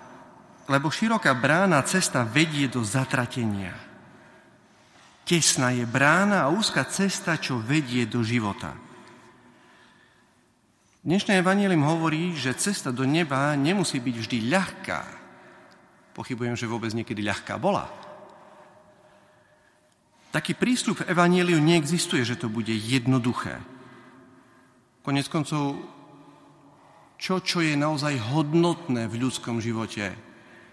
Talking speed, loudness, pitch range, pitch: 105 wpm, -24 LUFS, 120-170 Hz, 135 Hz